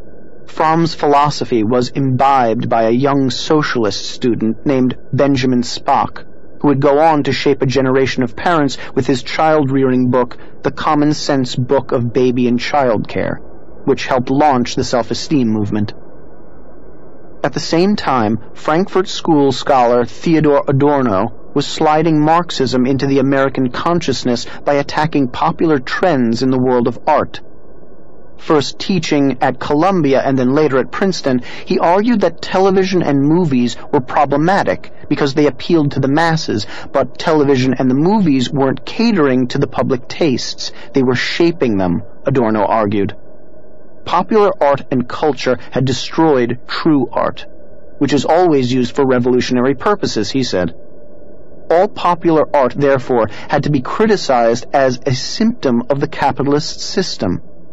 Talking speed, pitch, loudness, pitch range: 145 wpm, 135 Hz, -15 LUFS, 125-155 Hz